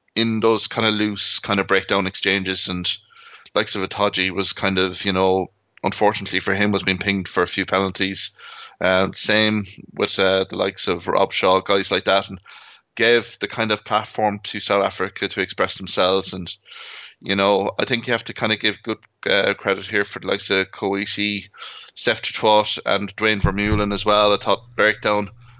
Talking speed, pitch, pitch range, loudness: 190 wpm, 100 Hz, 95-105 Hz, -20 LUFS